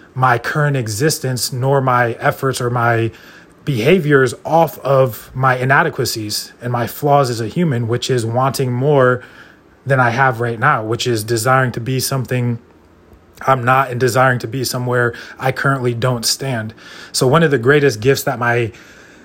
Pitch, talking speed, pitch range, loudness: 130 Hz, 165 wpm, 120-135 Hz, -16 LUFS